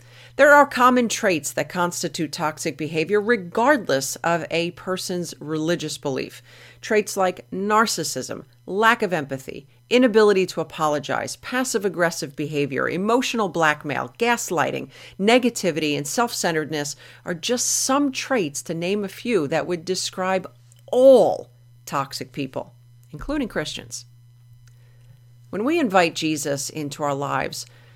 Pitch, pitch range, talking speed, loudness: 165 Hz, 140-210 Hz, 120 wpm, -21 LUFS